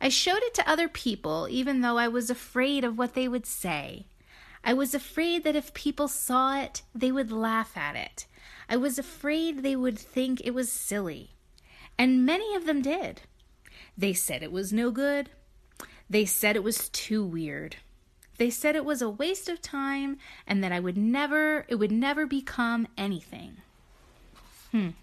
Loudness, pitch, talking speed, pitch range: -28 LUFS, 255 Hz, 175 wpm, 220-285 Hz